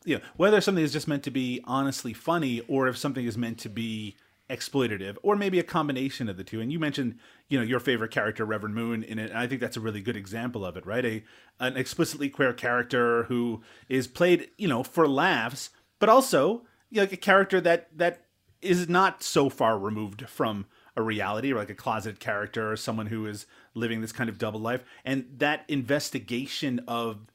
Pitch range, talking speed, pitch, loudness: 110-145 Hz, 215 wpm, 125 Hz, -27 LUFS